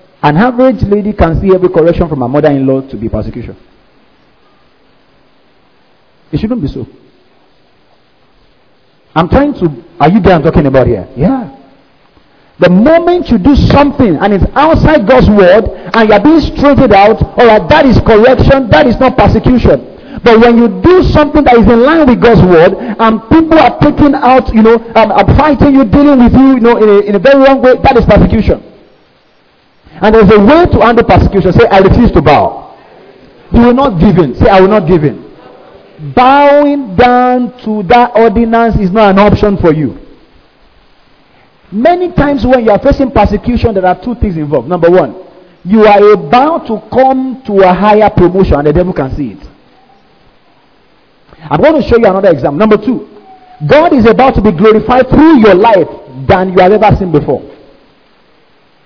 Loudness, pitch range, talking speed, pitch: -6 LUFS, 185-255 Hz, 180 wpm, 215 Hz